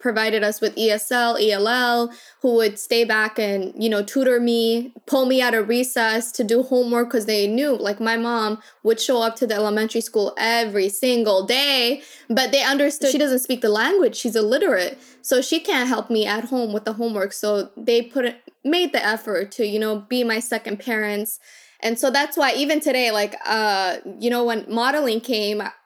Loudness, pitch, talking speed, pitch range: -20 LUFS, 235 Hz, 195 wpm, 215-255 Hz